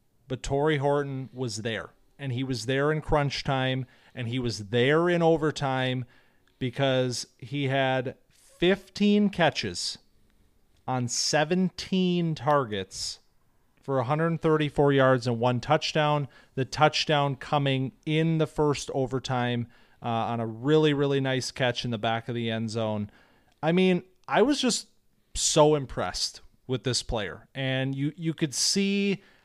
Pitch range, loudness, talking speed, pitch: 125-155 Hz, -27 LUFS, 140 wpm, 135 Hz